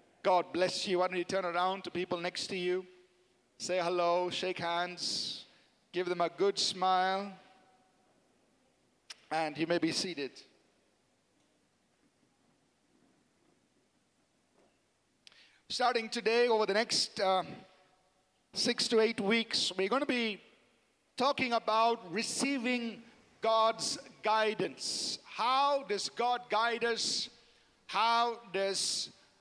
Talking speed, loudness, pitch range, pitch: 110 wpm, -32 LUFS, 180-230 Hz, 195 Hz